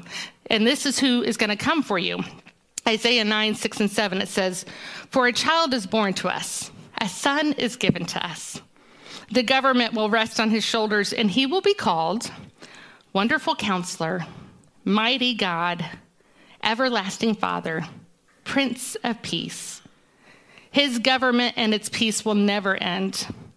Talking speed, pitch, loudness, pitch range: 150 wpm, 225 Hz, -23 LUFS, 205-255 Hz